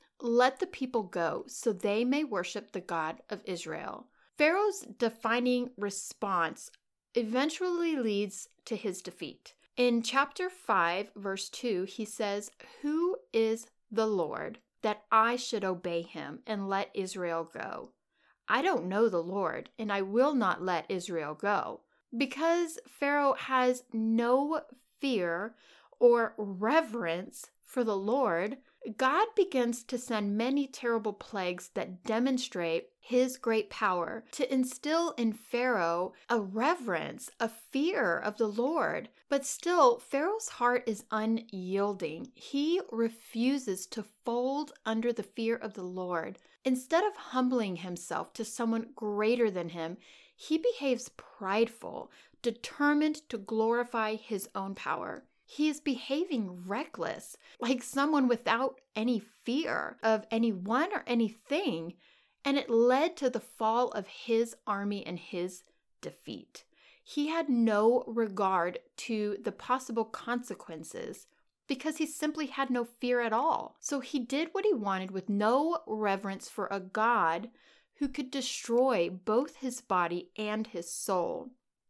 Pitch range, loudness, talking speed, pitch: 205-265 Hz, -32 LUFS, 135 wpm, 230 Hz